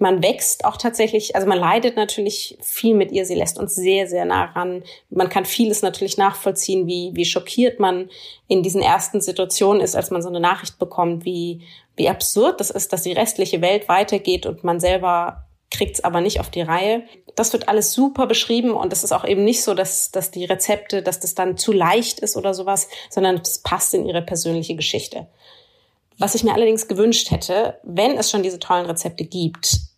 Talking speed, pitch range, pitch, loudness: 205 wpm, 180-210 Hz, 190 Hz, -19 LUFS